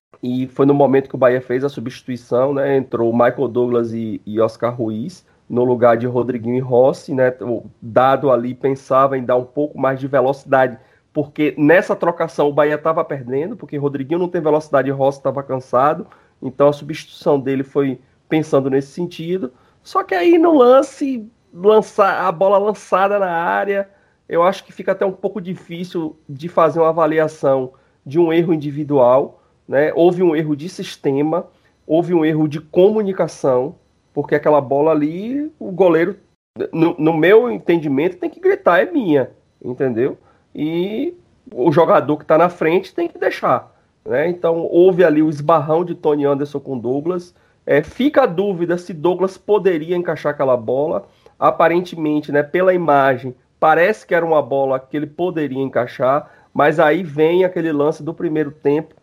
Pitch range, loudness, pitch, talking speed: 135-180 Hz, -17 LUFS, 155 Hz, 170 wpm